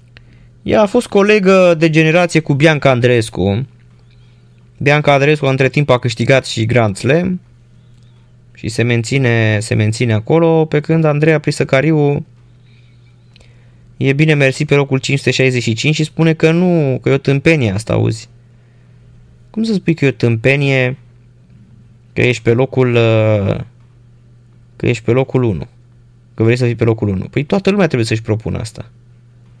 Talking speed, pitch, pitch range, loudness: 150 wpm, 120 Hz, 120-145 Hz, -13 LUFS